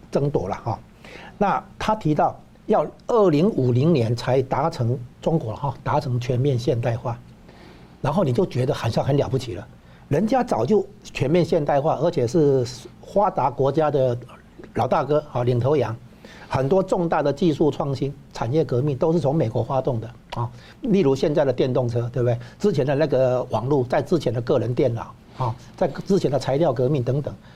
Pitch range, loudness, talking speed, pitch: 120-150 Hz, -22 LUFS, 270 characters per minute, 130 Hz